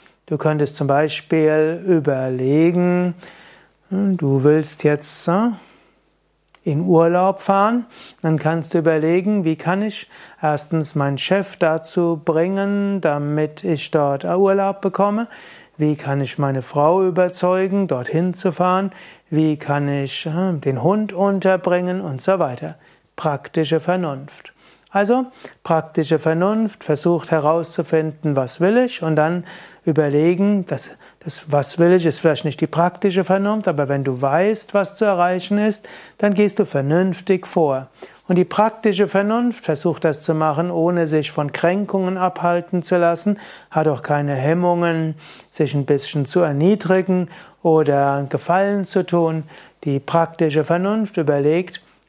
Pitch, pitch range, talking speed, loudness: 170 Hz, 155-190 Hz, 135 wpm, -19 LUFS